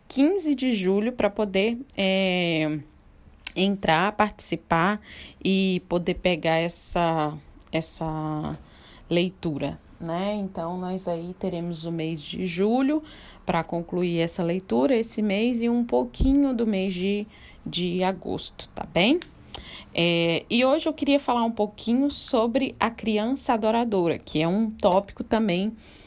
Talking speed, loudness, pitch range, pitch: 130 wpm, -25 LUFS, 170-225 Hz, 190 Hz